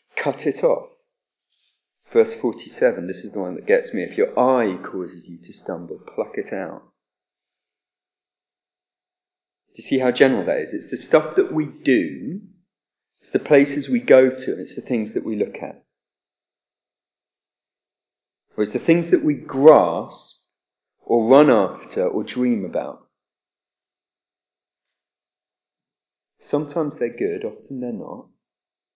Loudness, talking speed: -20 LUFS, 140 wpm